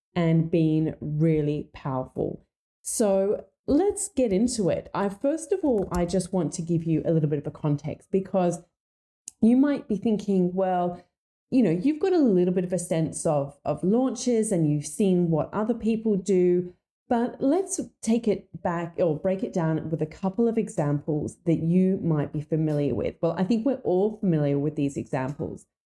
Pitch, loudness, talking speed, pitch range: 180 Hz, -25 LUFS, 185 wpm, 160-220 Hz